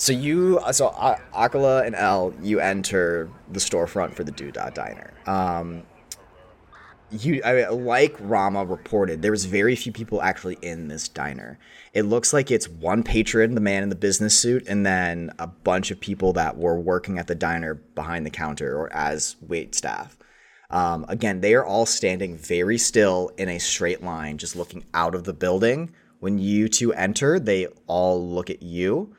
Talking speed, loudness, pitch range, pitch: 180 wpm, -23 LUFS, 85-110 Hz, 95 Hz